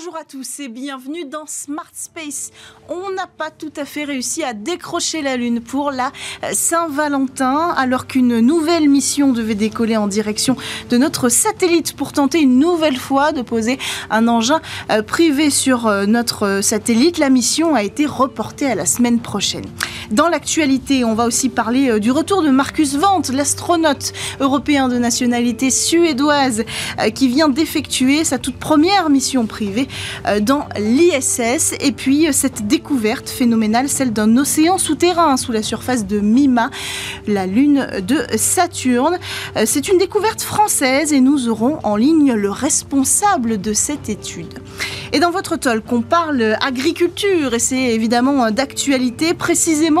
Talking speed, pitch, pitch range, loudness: 150 wpm, 275 Hz, 240-315 Hz, -16 LUFS